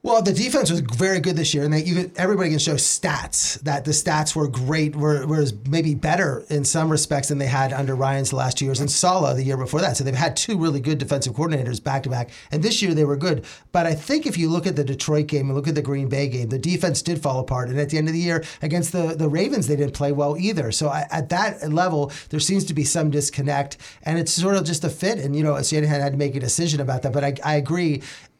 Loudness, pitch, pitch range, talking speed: -22 LUFS, 150 Hz, 140-165 Hz, 280 wpm